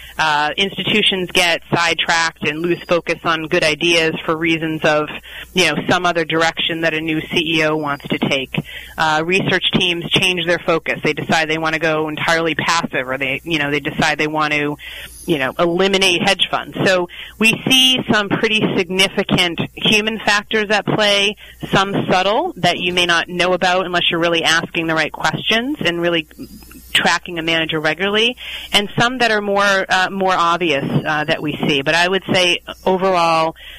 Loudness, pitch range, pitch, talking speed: -16 LUFS, 160-190 Hz, 170 Hz, 180 wpm